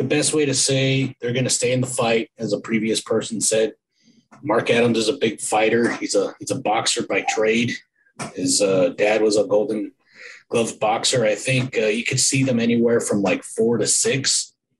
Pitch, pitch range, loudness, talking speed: 115 Hz, 110-130 Hz, -20 LUFS, 205 wpm